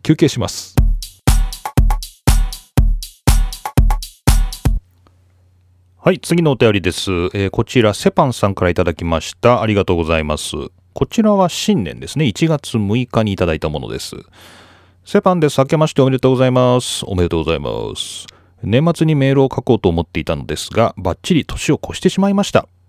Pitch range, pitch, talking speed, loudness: 90-135 Hz, 105 Hz, 335 characters per minute, -16 LUFS